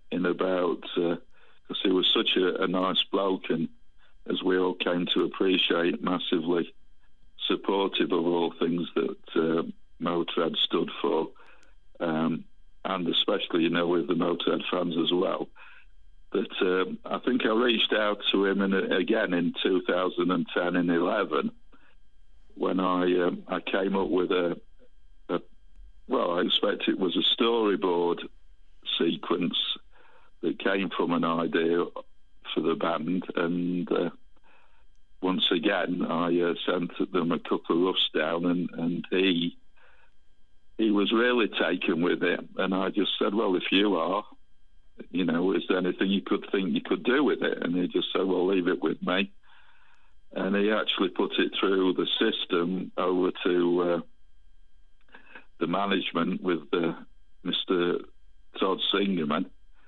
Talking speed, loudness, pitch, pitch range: 150 wpm, -27 LUFS, 90 Hz, 85-100 Hz